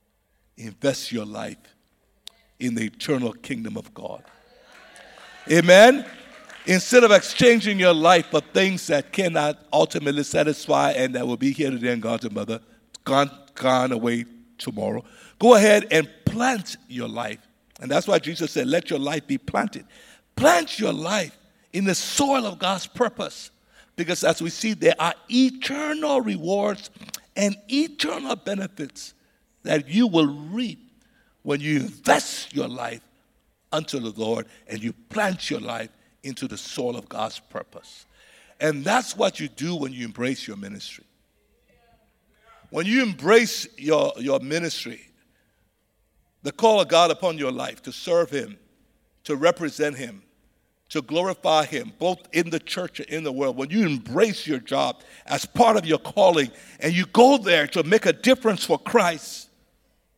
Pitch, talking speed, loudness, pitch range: 170 Hz, 155 wpm, -22 LUFS, 140-220 Hz